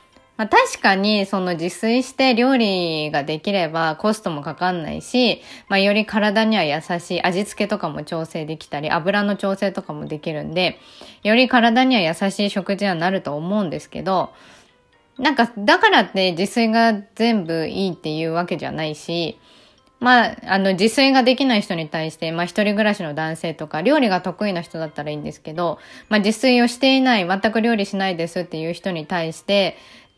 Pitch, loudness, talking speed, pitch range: 195 Hz, -19 LUFS, 365 characters per minute, 170-225 Hz